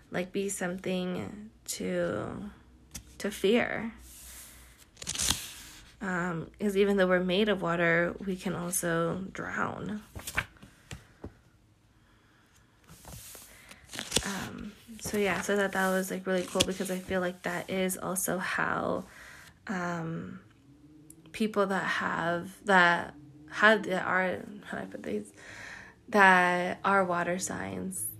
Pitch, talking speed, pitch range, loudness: 180 Hz, 115 wpm, 150-195 Hz, -29 LUFS